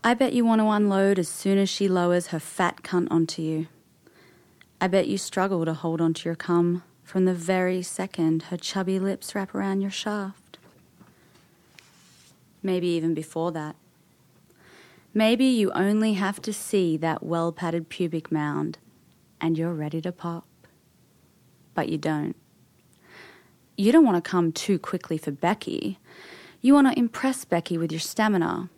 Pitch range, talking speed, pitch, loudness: 165-195 Hz, 160 wpm, 180 Hz, -25 LUFS